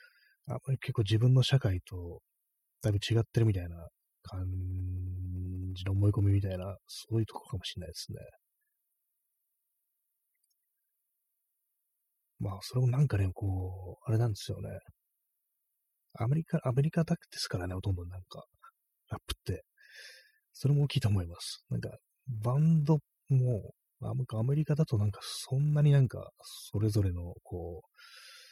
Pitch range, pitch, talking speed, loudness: 95-135 Hz, 110 Hz, 285 characters per minute, -32 LUFS